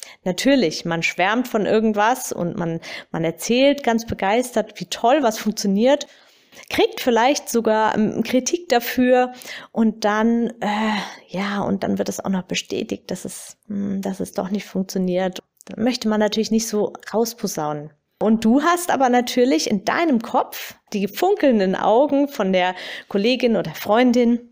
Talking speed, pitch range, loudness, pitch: 150 wpm, 195-250 Hz, -20 LUFS, 220 Hz